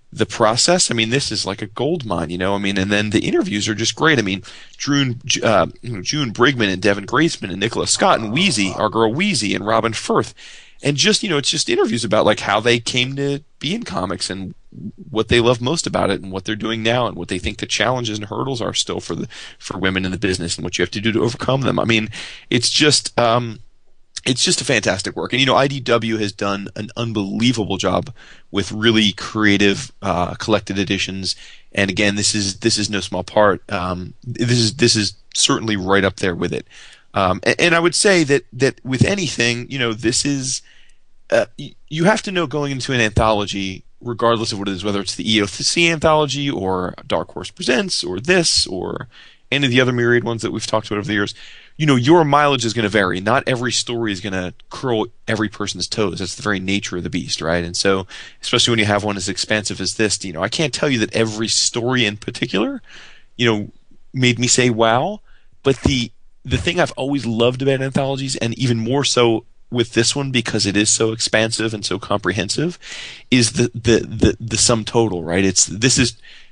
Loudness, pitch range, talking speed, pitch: -18 LUFS, 100-125 Hz, 220 wpm, 115 Hz